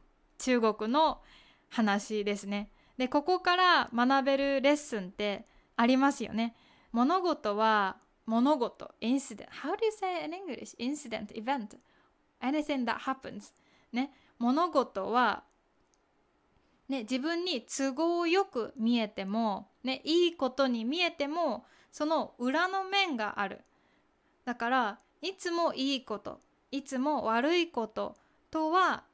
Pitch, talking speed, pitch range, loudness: 265 Hz, 300 characters per minute, 230-315 Hz, -31 LUFS